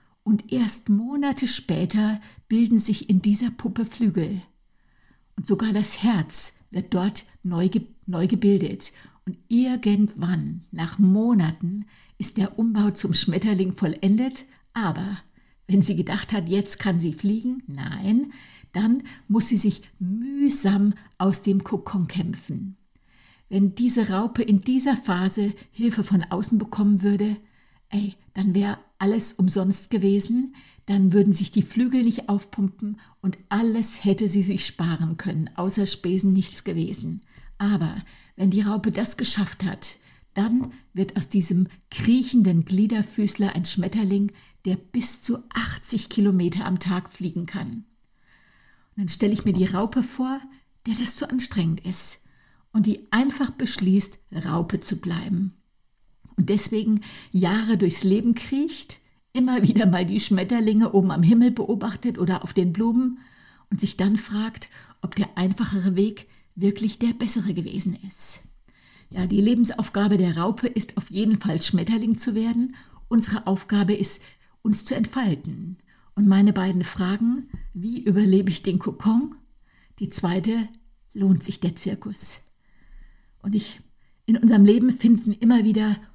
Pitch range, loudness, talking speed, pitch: 190-225 Hz, -23 LUFS, 140 wpm, 205 Hz